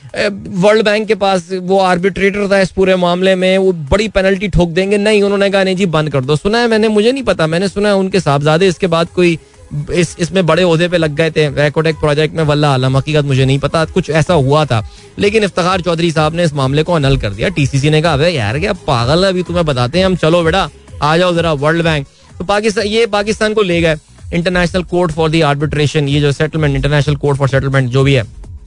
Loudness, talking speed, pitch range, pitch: -13 LUFS, 230 wpm, 150-195 Hz, 170 Hz